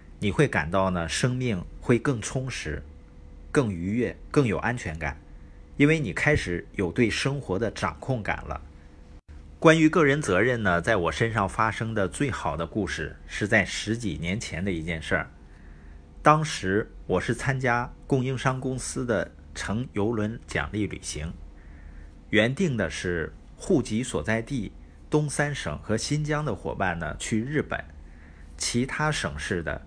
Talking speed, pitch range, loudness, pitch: 215 characters per minute, 75-125 Hz, -26 LUFS, 100 Hz